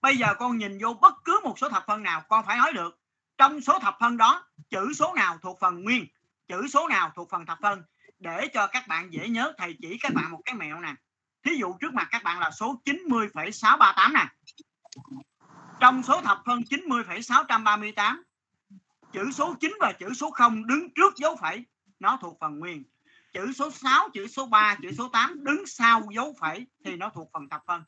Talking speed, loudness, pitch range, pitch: 210 wpm, -24 LUFS, 200-280 Hz, 230 Hz